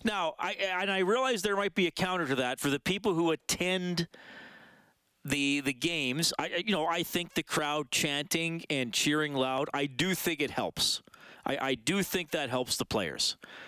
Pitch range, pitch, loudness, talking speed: 140-185 Hz, 165 Hz, -30 LUFS, 195 wpm